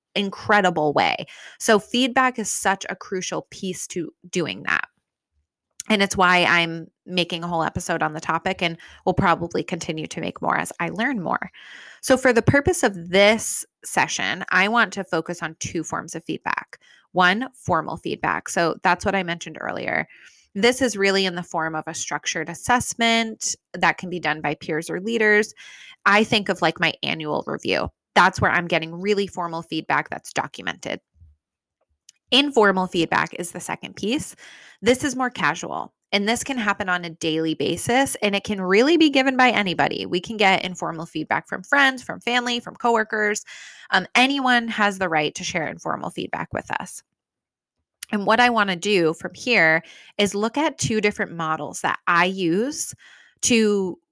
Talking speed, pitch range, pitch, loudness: 175 wpm, 165-220 Hz, 190 Hz, -21 LUFS